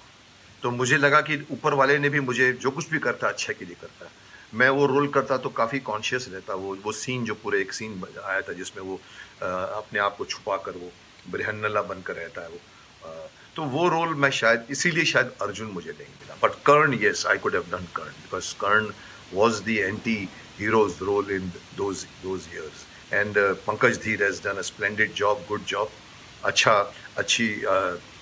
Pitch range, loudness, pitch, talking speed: 100-140 Hz, -24 LUFS, 120 Hz, 185 wpm